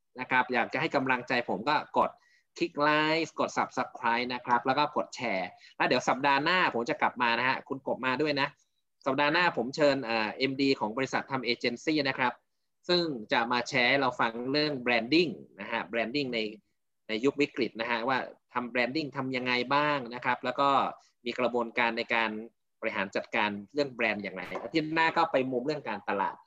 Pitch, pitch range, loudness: 125 Hz, 120-145 Hz, -29 LUFS